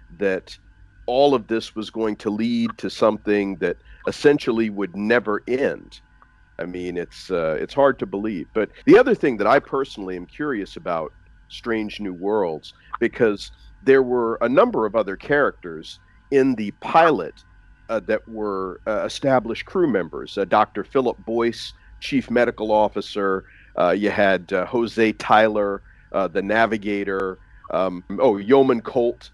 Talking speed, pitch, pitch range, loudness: 150 wpm, 105 Hz, 95-115 Hz, -21 LUFS